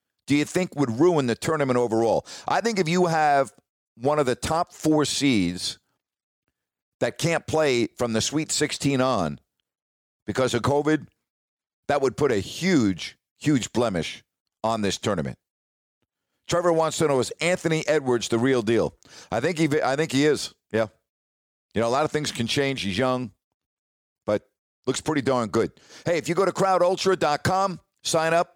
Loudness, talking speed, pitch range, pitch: -24 LUFS, 170 wpm, 120-165 Hz, 145 Hz